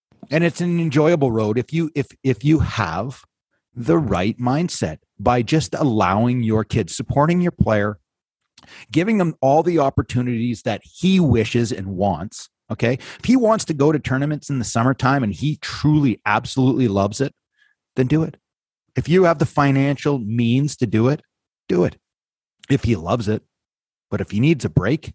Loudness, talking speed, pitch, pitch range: -19 LUFS, 175 wpm, 130 Hz, 115-155 Hz